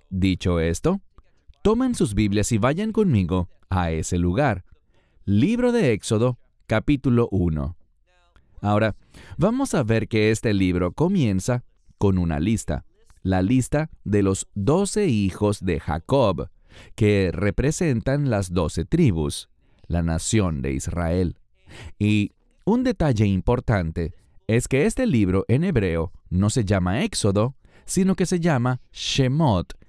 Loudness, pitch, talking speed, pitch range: -22 LUFS, 105 Hz, 125 wpm, 90-130 Hz